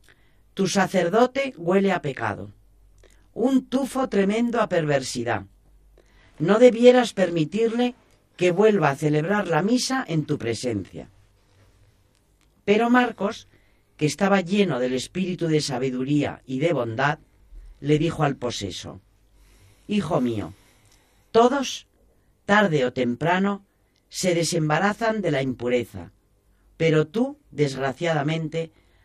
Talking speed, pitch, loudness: 105 wpm, 150 Hz, -23 LUFS